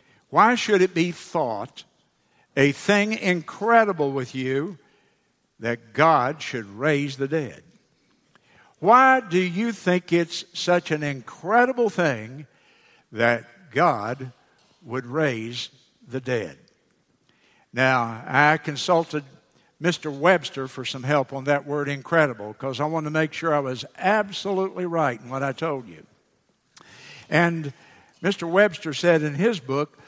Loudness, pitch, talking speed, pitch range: -23 LUFS, 150 Hz, 130 wpm, 135-180 Hz